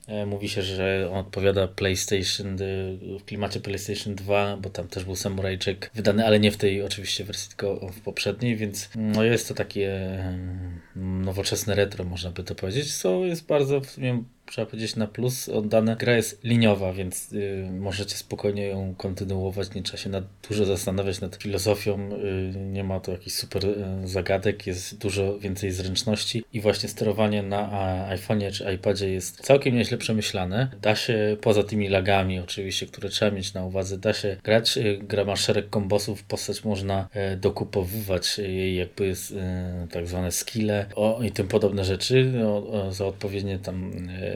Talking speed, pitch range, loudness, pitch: 170 wpm, 95-105 Hz, -26 LUFS, 100 Hz